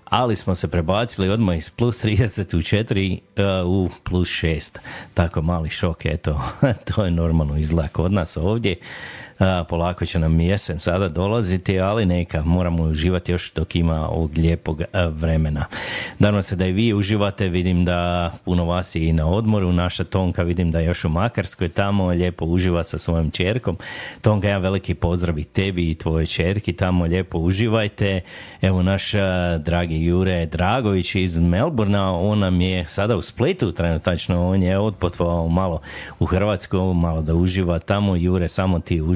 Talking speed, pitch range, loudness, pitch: 165 wpm, 85-100 Hz, -21 LUFS, 90 Hz